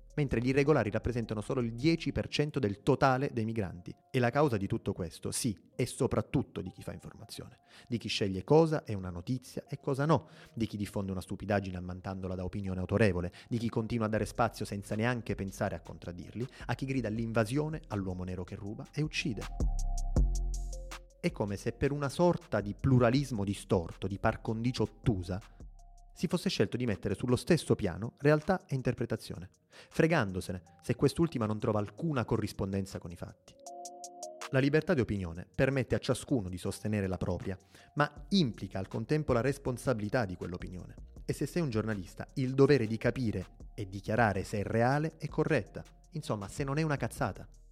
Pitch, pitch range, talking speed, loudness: 115 Hz, 100-140 Hz, 175 wpm, -33 LUFS